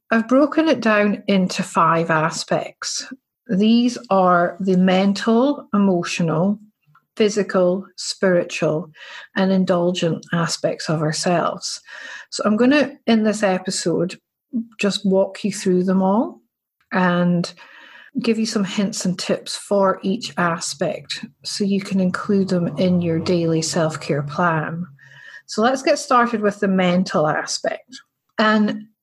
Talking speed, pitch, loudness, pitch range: 125 wpm, 195 Hz, -19 LUFS, 175-220 Hz